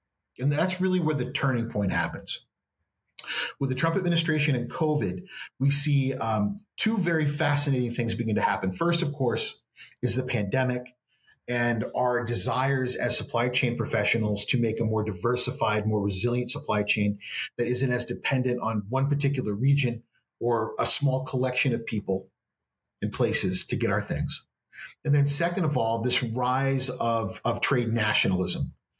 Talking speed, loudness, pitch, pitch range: 160 wpm, -26 LUFS, 125 Hz, 115-135 Hz